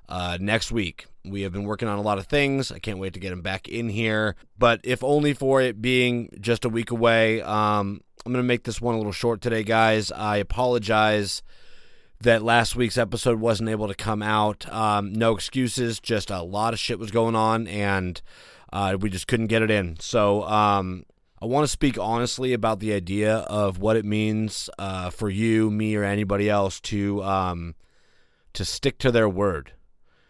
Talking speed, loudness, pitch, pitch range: 200 wpm, -24 LUFS, 110 Hz, 100-115 Hz